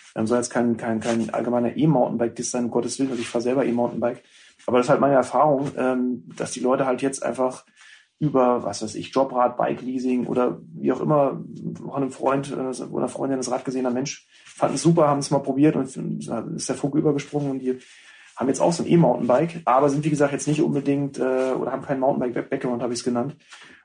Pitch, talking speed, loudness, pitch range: 130 Hz, 215 wpm, -23 LUFS, 120-140 Hz